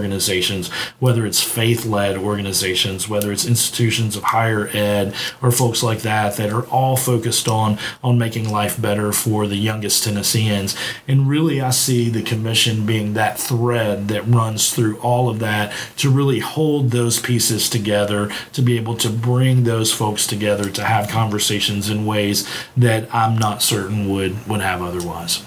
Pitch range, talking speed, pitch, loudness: 105-120 Hz, 165 wpm, 110 Hz, -18 LUFS